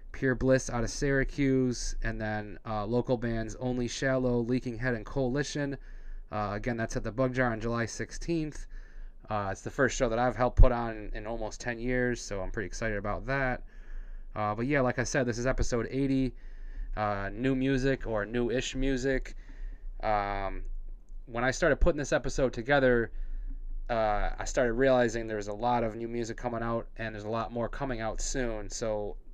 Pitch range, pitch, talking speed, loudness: 110-130 Hz, 120 Hz, 185 wpm, -31 LUFS